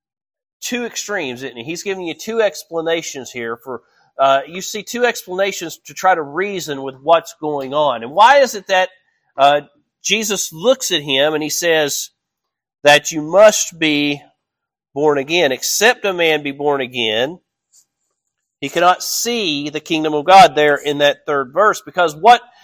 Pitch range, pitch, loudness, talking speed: 145-190 Hz, 160 Hz, -16 LUFS, 165 wpm